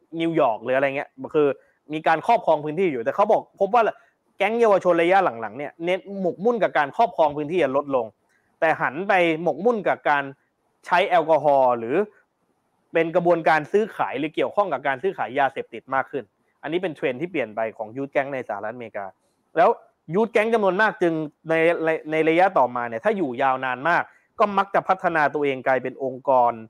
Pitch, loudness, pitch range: 160 Hz, -22 LUFS, 140-195 Hz